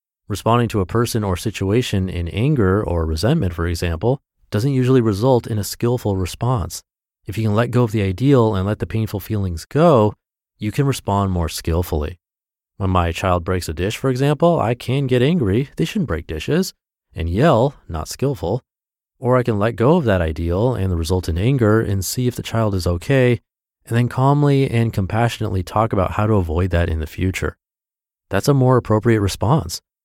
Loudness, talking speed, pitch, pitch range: -19 LUFS, 195 wpm, 105 Hz, 90-125 Hz